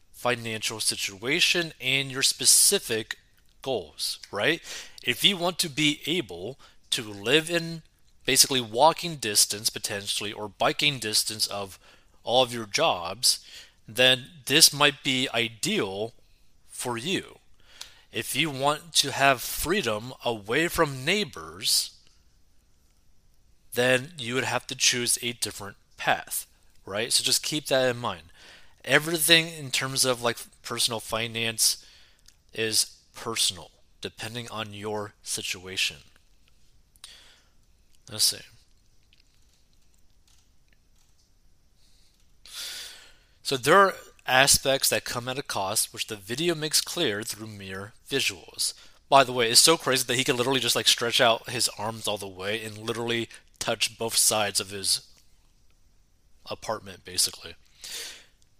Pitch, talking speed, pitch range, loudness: 115 Hz, 125 wpm, 100-135 Hz, -24 LUFS